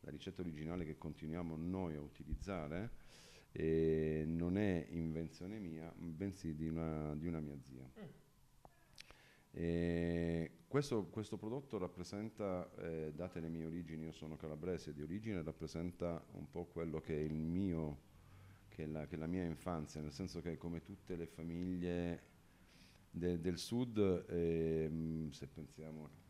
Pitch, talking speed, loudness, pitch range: 85 Hz, 150 wpm, -43 LUFS, 80-90 Hz